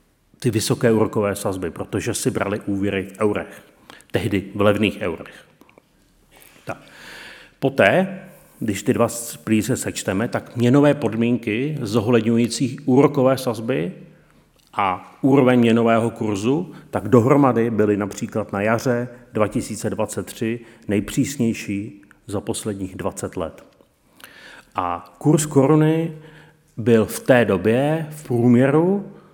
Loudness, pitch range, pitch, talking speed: -20 LUFS, 105-135 Hz, 115 Hz, 105 wpm